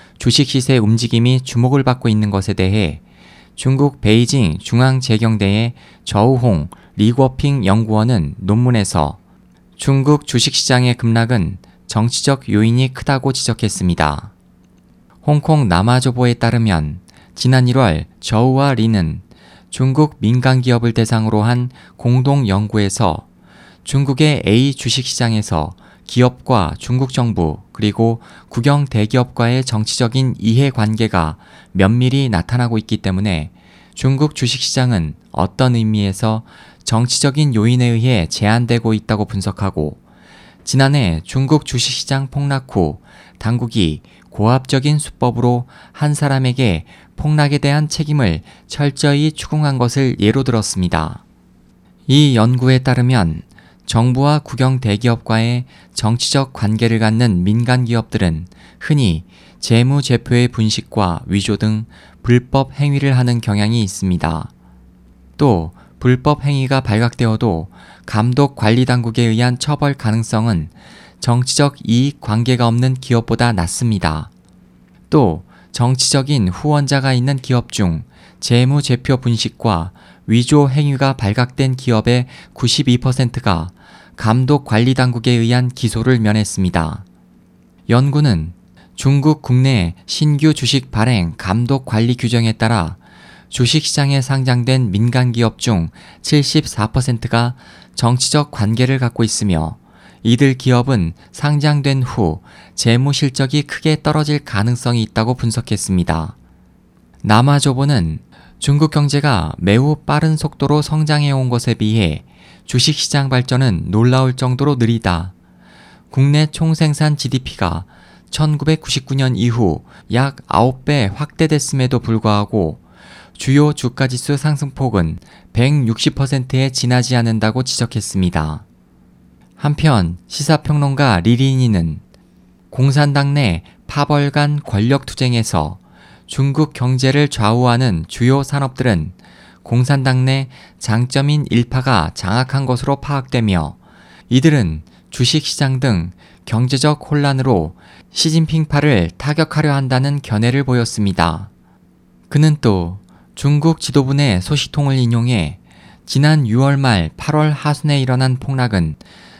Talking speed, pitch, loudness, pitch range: 255 characters per minute, 125 Hz, -15 LUFS, 105-135 Hz